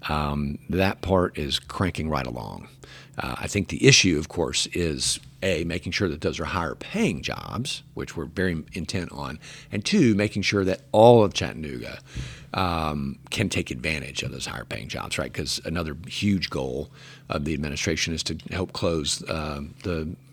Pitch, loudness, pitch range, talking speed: 85 Hz, -25 LUFS, 75-95 Hz, 175 wpm